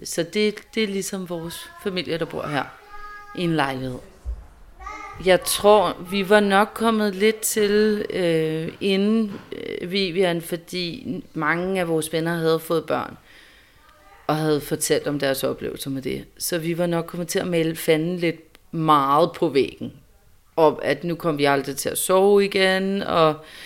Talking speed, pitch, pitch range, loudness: 165 wpm, 175 Hz, 160-205 Hz, -22 LUFS